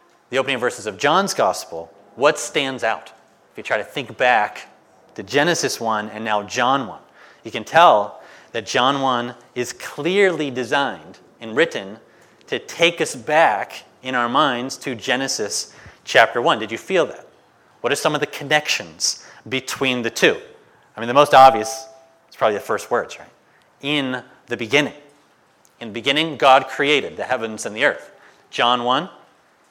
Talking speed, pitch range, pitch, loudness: 170 wpm, 115-145 Hz, 130 Hz, -19 LUFS